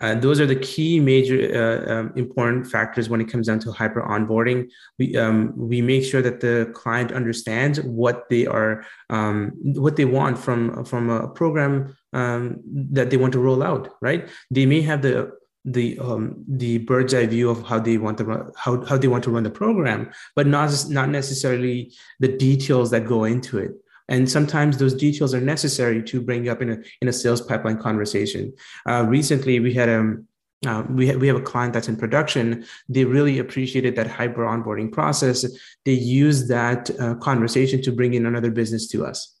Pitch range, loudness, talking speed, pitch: 115-135 Hz, -21 LUFS, 200 wpm, 125 Hz